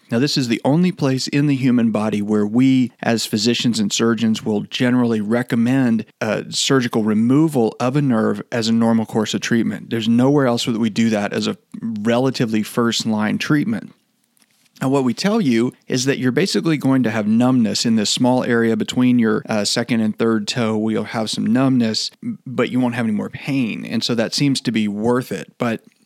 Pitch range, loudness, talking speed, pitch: 115-140 Hz, -18 LUFS, 205 wpm, 120 Hz